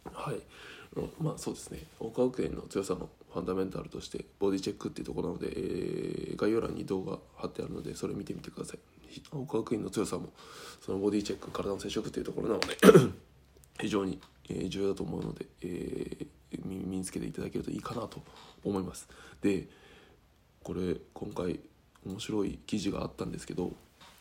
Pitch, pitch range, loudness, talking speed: 95 Hz, 95-110 Hz, -34 LUFS, 380 characters per minute